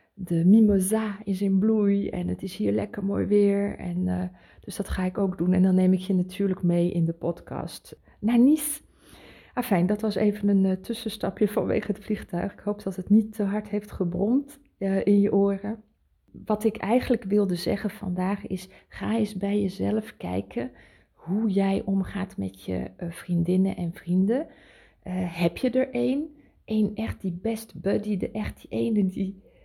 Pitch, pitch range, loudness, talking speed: 200 Hz, 185-215 Hz, -26 LUFS, 185 wpm